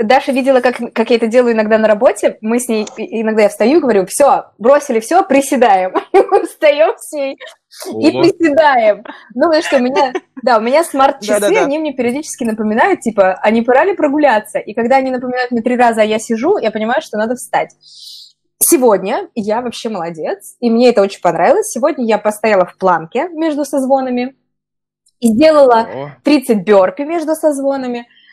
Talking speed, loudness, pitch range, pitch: 165 wpm, -13 LUFS, 225-295 Hz, 250 Hz